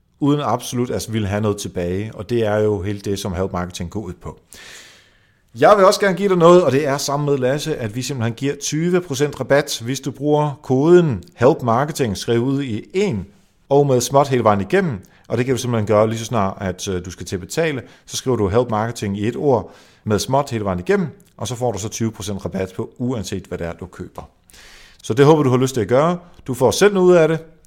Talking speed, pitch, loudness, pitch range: 240 wpm, 120 Hz, -18 LUFS, 105-145 Hz